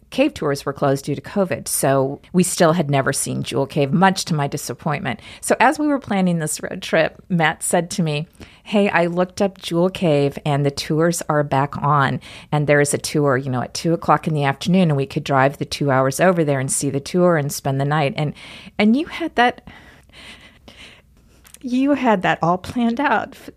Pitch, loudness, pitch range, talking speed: 160 Hz, -19 LUFS, 140-190 Hz, 215 wpm